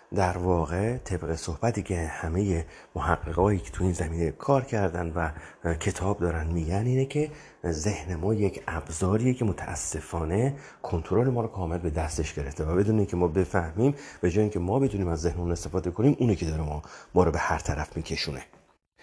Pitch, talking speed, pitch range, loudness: 90 Hz, 175 wpm, 85-105 Hz, -28 LUFS